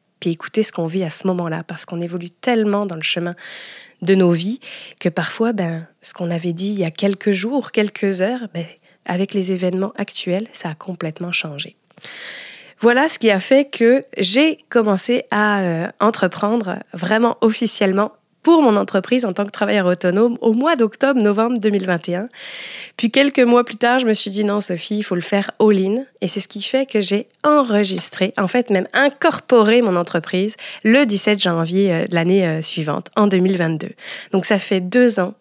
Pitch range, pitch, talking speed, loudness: 180-230 Hz, 205 Hz, 185 wpm, -17 LUFS